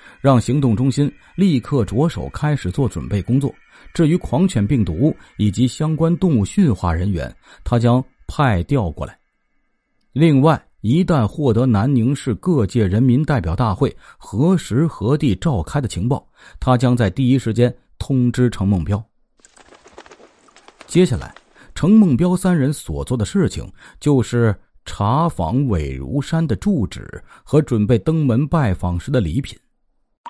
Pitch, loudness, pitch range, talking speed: 125 Hz, -18 LUFS, 105-150 Hz, 220 characters per minute